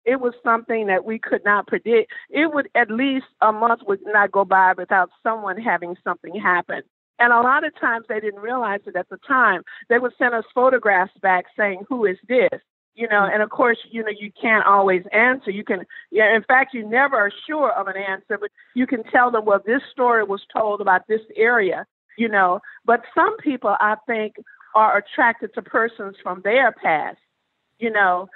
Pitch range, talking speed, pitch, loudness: 200-245 Hz, 205 wpm, 220 Hz, -19 LUFS